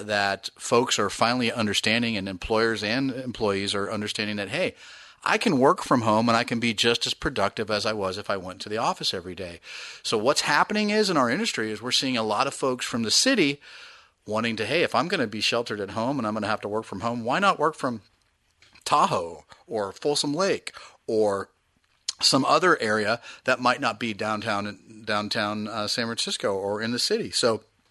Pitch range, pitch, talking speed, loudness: 105-125 Hz, 110 Hz, 215 wpm, -25 LUFS